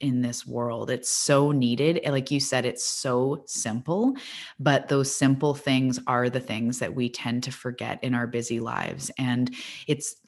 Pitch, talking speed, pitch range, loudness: 130 Hz, 175 wpm, 125-140 Hz, -26 LUFS